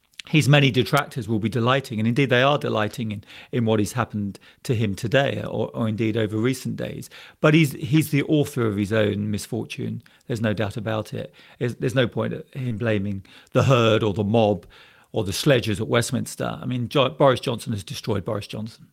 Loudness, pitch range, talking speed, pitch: -23 LUFS, 110-135 Hz, 205 wpm, 115 Hz